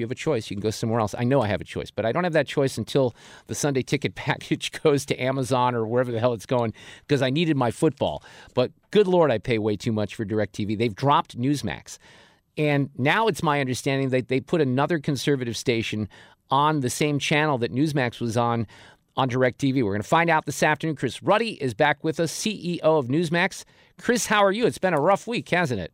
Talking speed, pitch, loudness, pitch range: 235 wpm, 135 Hz, -24 LUFS, 120-155 Hz